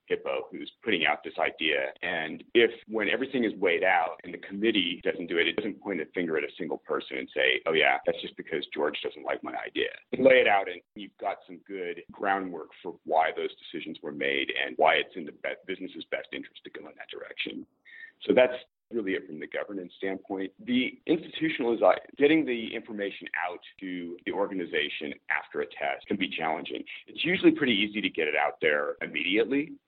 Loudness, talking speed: -28 LUFS, 210 wpm